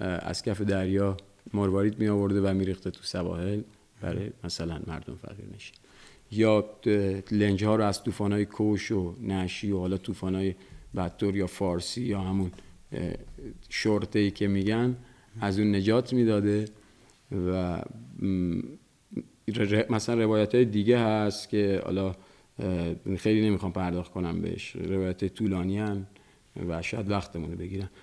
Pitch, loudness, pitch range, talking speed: 100 Hz, -29 LUFS, 95-105 Hz, 130 wpm